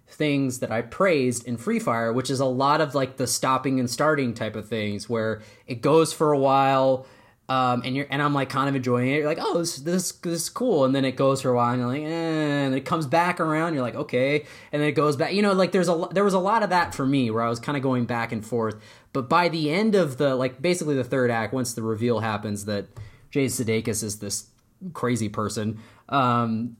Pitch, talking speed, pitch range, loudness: 130 Hz, 255 wpm, 115-150 Hz, -24 LUFS